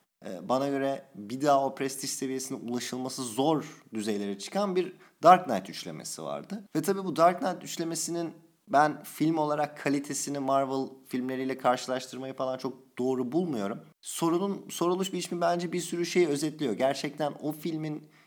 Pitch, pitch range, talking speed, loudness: 145 Hz, 130-170 Hz, 145 wpm, -30 LUFS